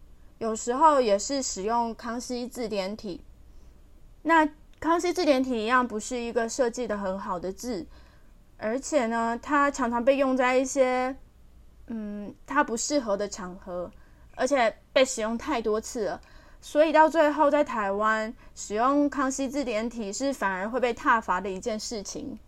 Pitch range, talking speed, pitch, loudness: 210-270 Hz, 230 characters per minute, 235 Hz, -26 LUFS